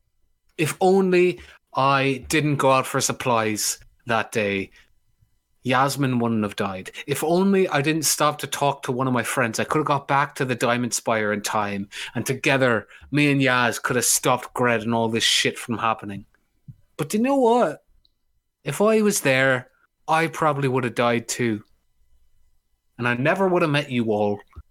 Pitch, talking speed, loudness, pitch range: 130 Hz, 180 wpm, -22 LUFS, 115-150 Hz